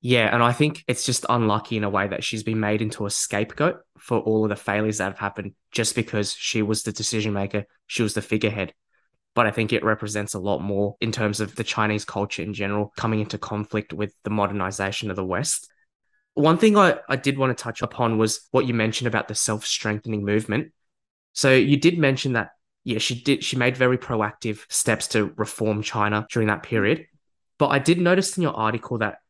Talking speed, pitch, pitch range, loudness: 215 wpm, 110 Hz, 105-120 Hz, -23 LUFS